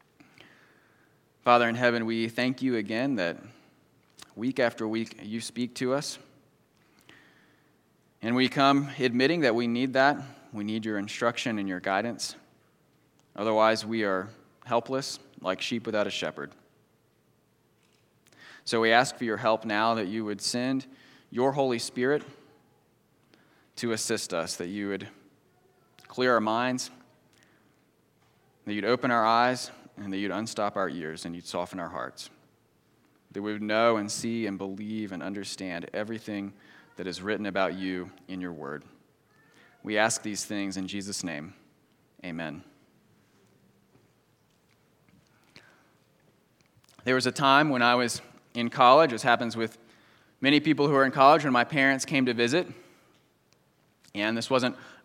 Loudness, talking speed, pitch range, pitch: -27 LUFS, 145 wpm, 105-125 Hz, 115 Hz